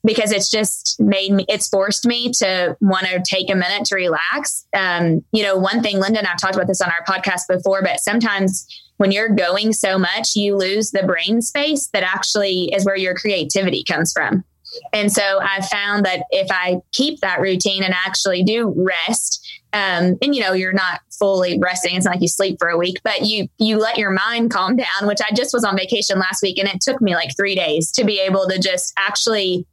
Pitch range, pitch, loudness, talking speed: 185-215 Hz, 195 Hz, -17 LUFS, 220 wpm